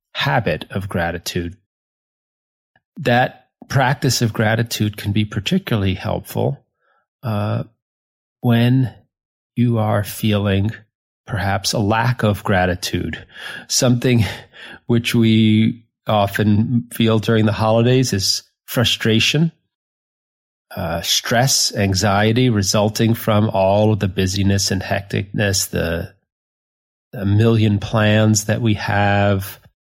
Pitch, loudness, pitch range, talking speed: 110 Hz, -18 LUFS, 100-115 Hz, 100 wpm